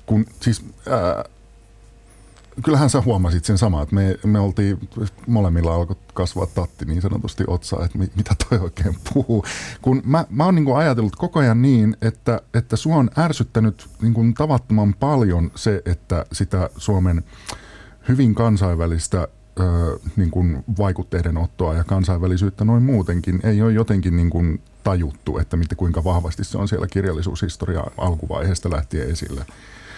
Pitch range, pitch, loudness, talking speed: 90-115 Hz, 100 Hz, -20 LUFS, 150 wpm